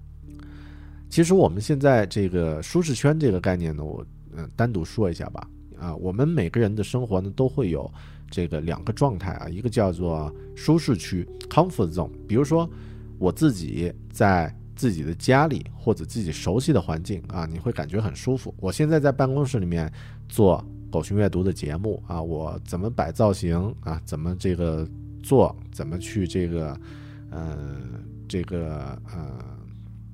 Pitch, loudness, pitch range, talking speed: 100 Hz, -25 LUFS, 85-120 Hz, 260 characters per minute